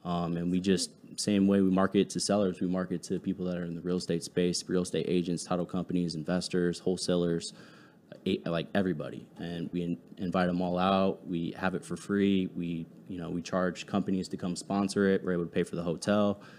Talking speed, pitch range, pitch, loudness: 210 wpm, 85-95 Hz, 90 Hz, -31 LUFS